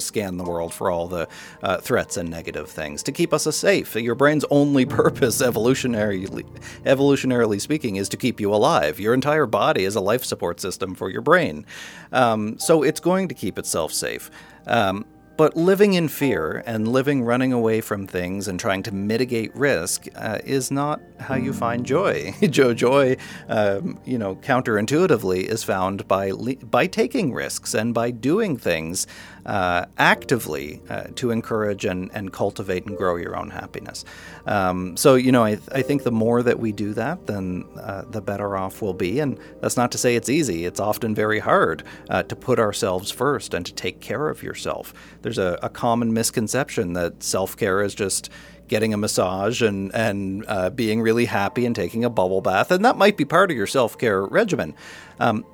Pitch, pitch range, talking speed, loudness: 110 Hz, 95-130 Hz, 190 wpm, -22 LUFS